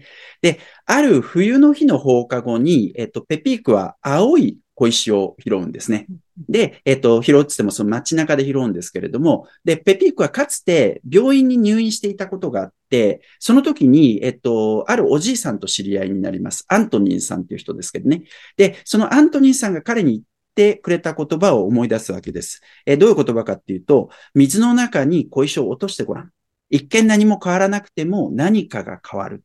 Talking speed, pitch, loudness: 385 characters per minute, 180 Hz, -17 LUFS